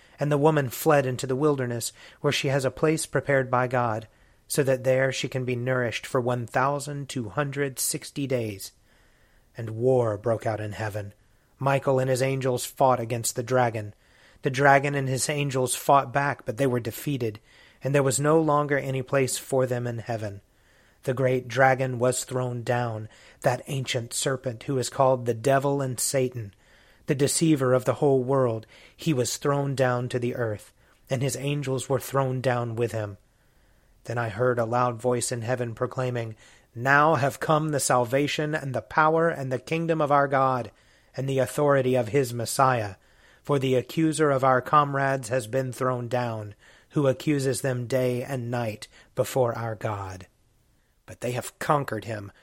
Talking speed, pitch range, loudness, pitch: 175 wpm, 120-140 Hz, -25 LUFS, 130 Hz